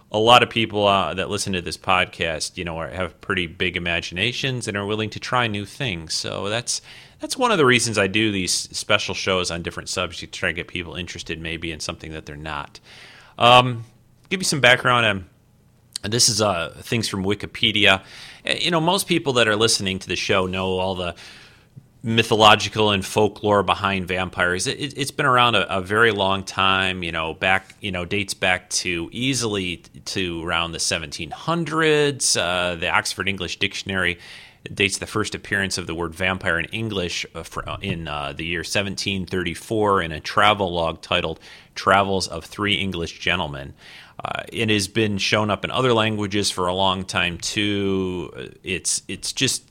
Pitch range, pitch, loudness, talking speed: 90-115 Hz, 100 Hz, -21 LUFS, 185 wpm